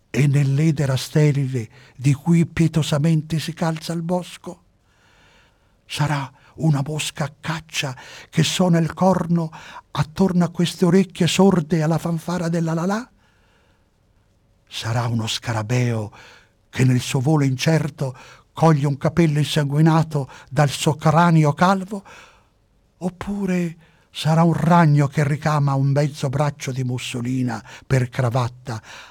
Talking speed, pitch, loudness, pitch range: 115 wpm, 150 Hz, -20 LUFS, 125-165 Hz